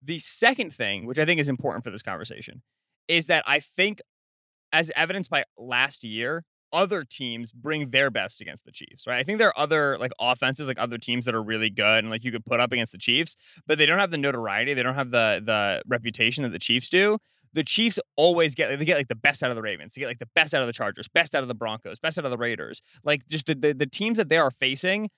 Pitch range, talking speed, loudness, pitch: 120-165 Hz, 260 wpm, -24 LUFS, 140 Hz